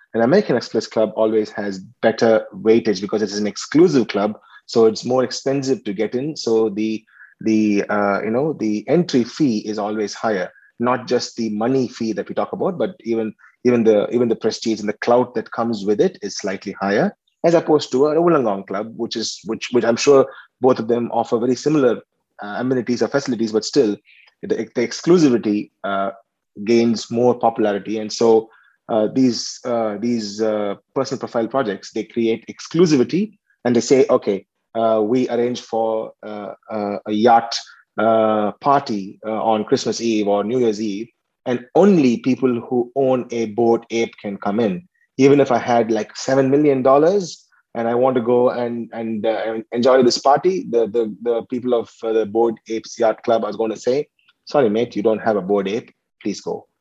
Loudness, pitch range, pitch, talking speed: -19 LUFS, 110-125 Hz, 115 Hz, 190 wpm